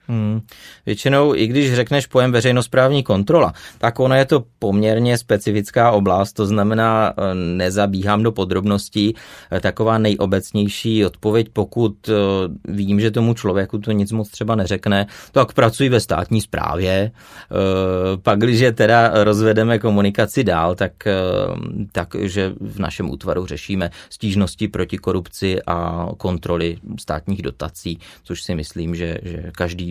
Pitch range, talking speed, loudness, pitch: 95-110 Hz, 130 wpm, -18 LUFS, 100 Hz